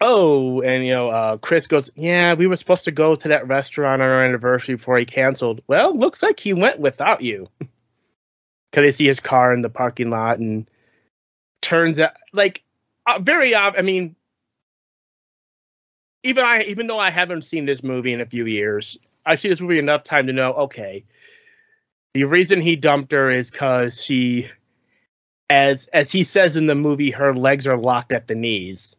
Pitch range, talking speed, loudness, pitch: 125-170 Hz, 190 wpm, -18 LUFS, 140 Hz